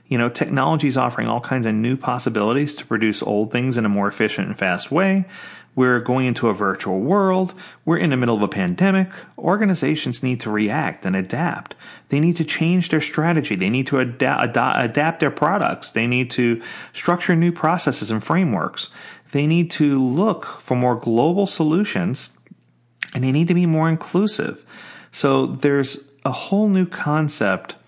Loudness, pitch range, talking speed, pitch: -20 LUFS, 120-170 Hz, 175 wpm, 140 Hz